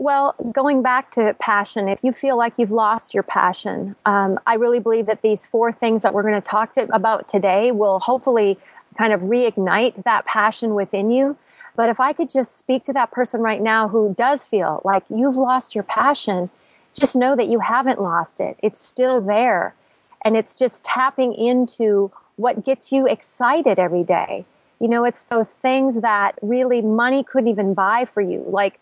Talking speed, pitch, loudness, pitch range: 190 wpm, 230 Hz, -19 LUFS, 205-255 Hz